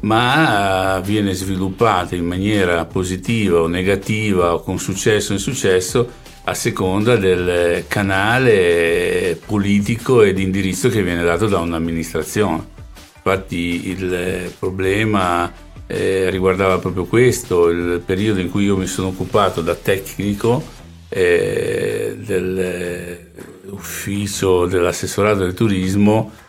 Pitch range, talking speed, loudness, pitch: 90-110 Hz, 110 wpm, -17 LUFS, 95 Hz